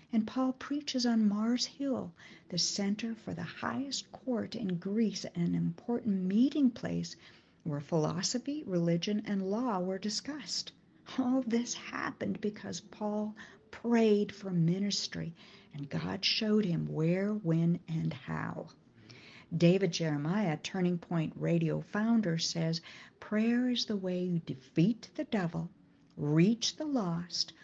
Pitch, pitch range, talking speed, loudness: 200 Hz, 170-225 Hz, 130 wpm, -33 LUFS